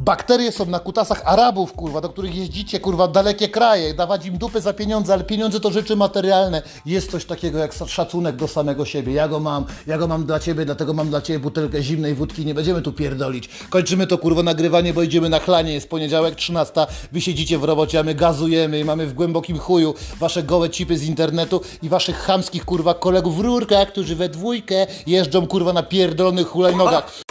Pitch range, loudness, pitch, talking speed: 155-190 Hz, -19 LUFS, 170 Hz, 205 wpm